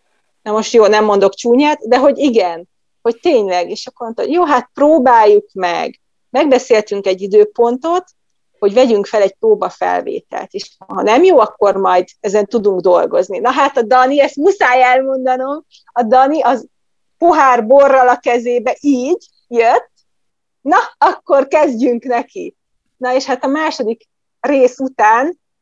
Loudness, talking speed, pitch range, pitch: -13 LUFS, 145 wpm, 220-285 Hz, 250 Hz